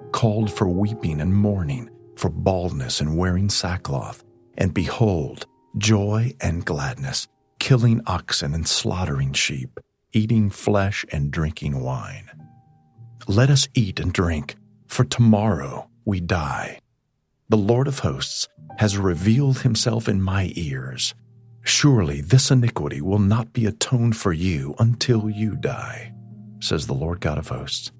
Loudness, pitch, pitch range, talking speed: -22 LUFS, 110 Hz, 90-120 Hz, 135 wpm